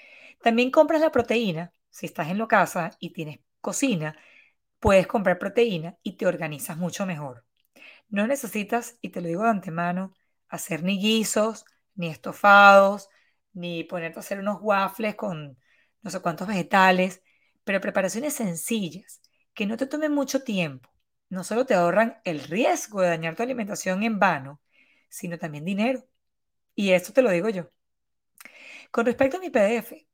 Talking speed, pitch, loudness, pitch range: 155 wpm, 200 Hz, -24 LUFS, 175-230 Hz